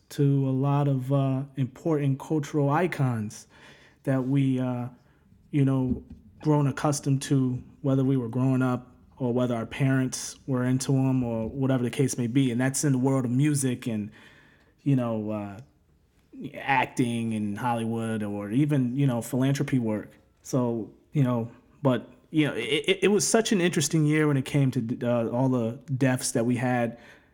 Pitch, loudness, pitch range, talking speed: 130 Hz, -26 LUFS, 120-140 Hz, 170 wpm